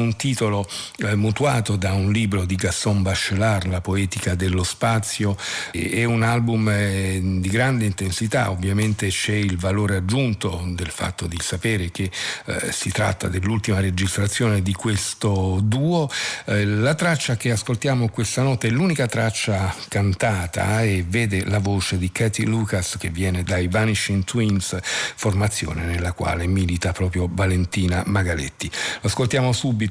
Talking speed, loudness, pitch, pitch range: 135 wpm, -22 LUFS, 100 Hz, 95-110 Hz